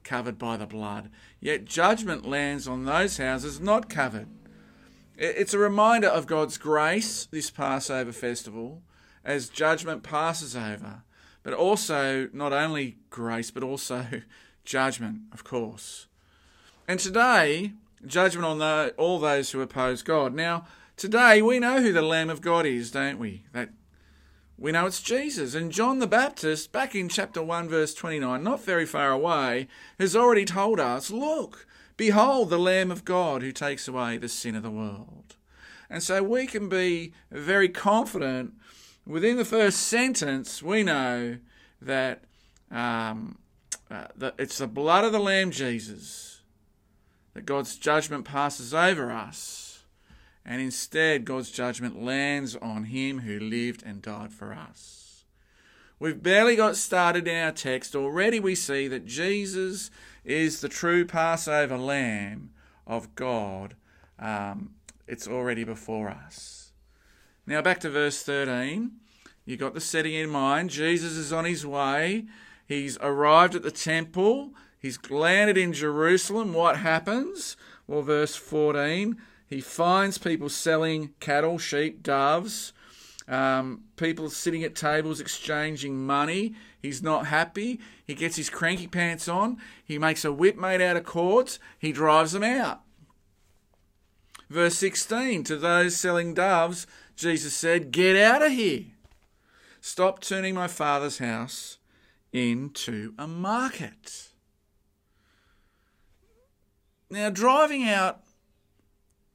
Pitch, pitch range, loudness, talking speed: 155 Hz, 125-185 Hz, -26 LUFS, 135 wpm